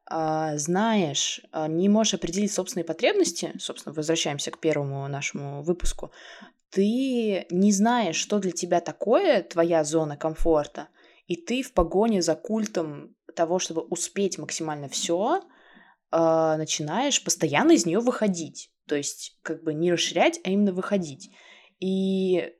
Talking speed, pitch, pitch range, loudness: 125 wpm, 175 Hz, 160-200 Hz, -25 LUFS